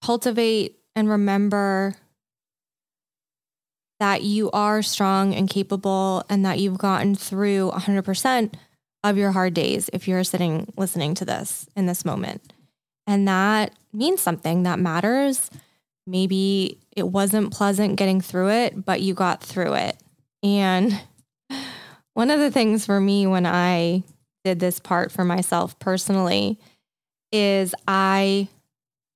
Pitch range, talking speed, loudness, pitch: 180-205 Hz, 130 wpm, -22 LUFS, 195 Hz